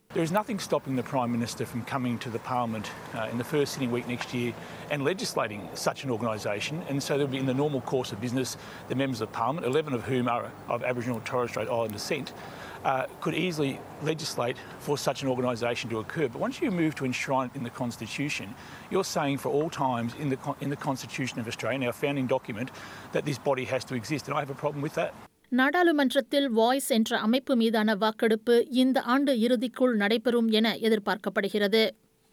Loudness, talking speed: -28 LUFS, 200 wpm